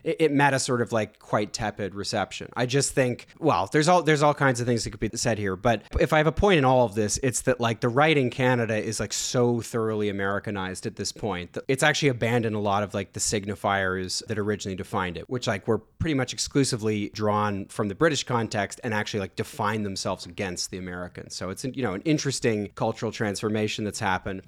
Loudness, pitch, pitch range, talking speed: -25 LUFS, 110 Hz, 100-130 Hz, 230 wpm